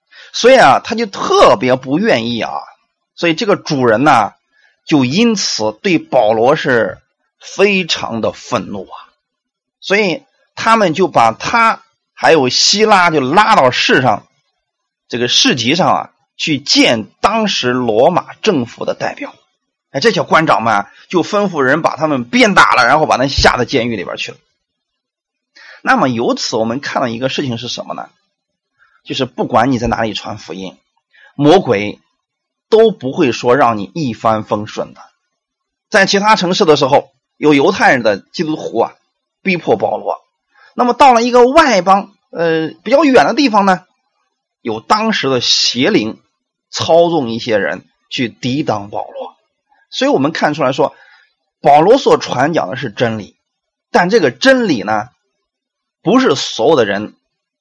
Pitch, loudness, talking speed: 185 Hz, -12 LUFS, 225 characters per minute